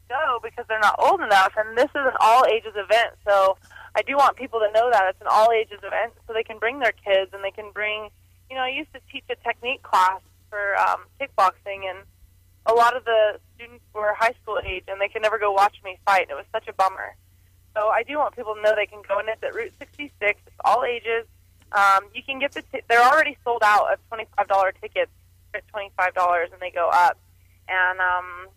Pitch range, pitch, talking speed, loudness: 190-230 Hz, 210 Hz, 240 wpm, -22 LUFS